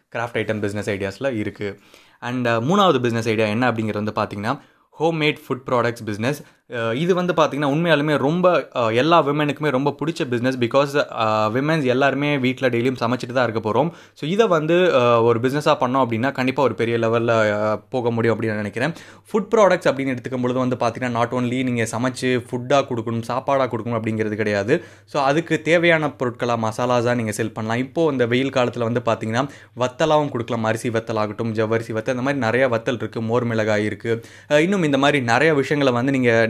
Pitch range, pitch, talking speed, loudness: 115-140 Hz, 125 Hz, 170 wpm, -20 LUFS